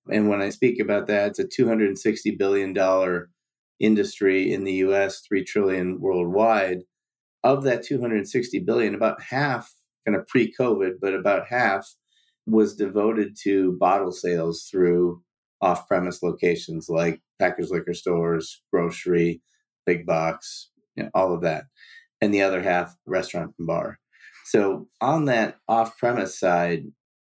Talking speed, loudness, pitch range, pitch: 135 wpm, -23 LUFS, 90-110 Hz, 95 Hz